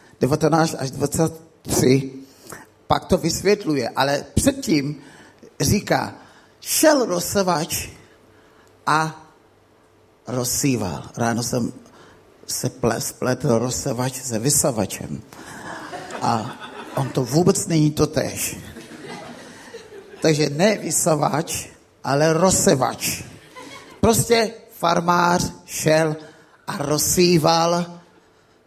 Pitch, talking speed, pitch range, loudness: 155 Hz, 75 wpm, 130-175 Hz, -20 LUFS